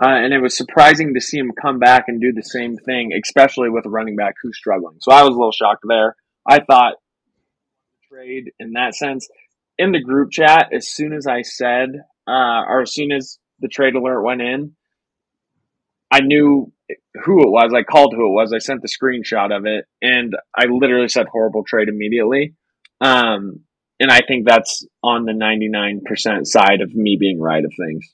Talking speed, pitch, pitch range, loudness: 195 wpm, 125 Hz, 110-135 Hz, -15 LUFS